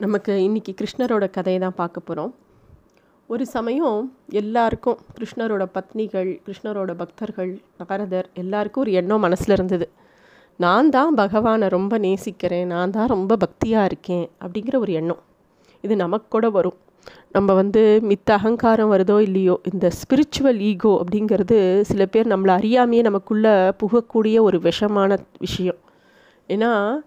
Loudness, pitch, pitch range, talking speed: -20 LUFS, 205 Hz, 185-225 Hz, 125 wpm